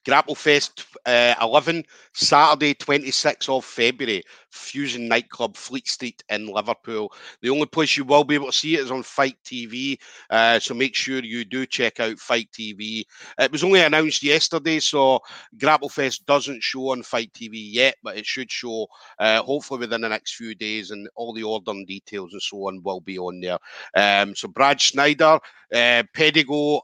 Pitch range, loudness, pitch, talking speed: 110-145 Hz, -21 LUFS, 130 Hz, 185 wpm